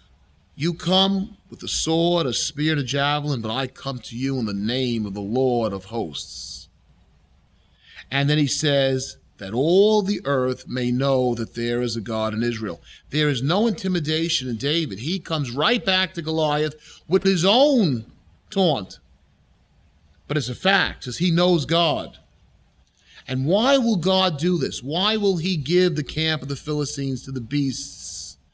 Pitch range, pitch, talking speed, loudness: 110-170 Hz, 140 Hz, 170 wpm, -22 LUFS